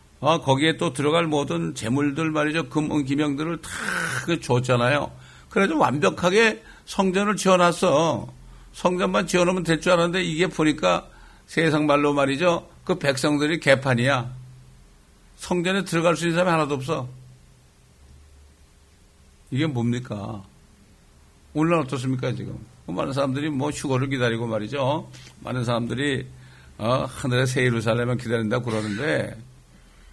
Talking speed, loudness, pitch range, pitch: 295 characters per minute, -23 LUFS, 105-160 Hz, 135 Hz